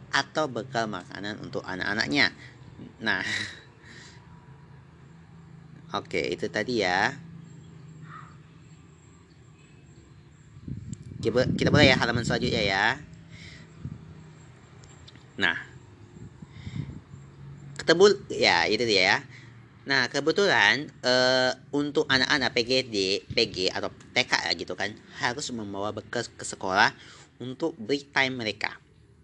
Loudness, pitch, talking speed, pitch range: -25 LUFS, 140 Hz, 90 wpm, 120-155 Hz